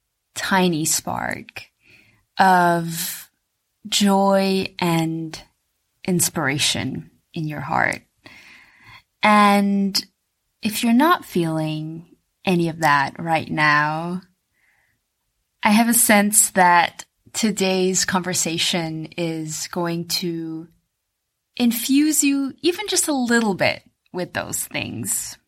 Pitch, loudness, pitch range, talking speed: 175 Hz, -19 LUFS, 160-205 Hz, 90 wpm